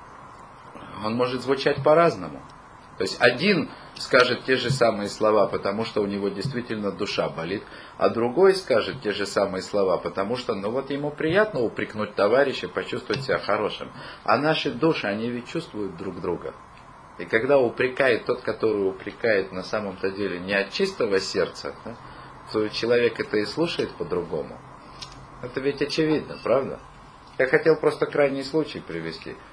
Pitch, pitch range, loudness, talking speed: 125 Hz, 100-150 Hz, -24 LUFS, 150 wpm